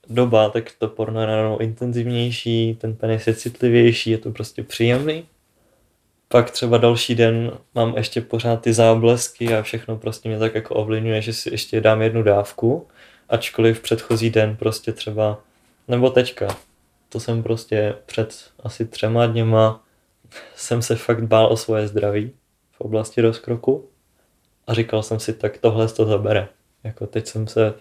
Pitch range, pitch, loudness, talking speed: 110-115 Hz, 115 Hz, -20 LUFS, 160 wpm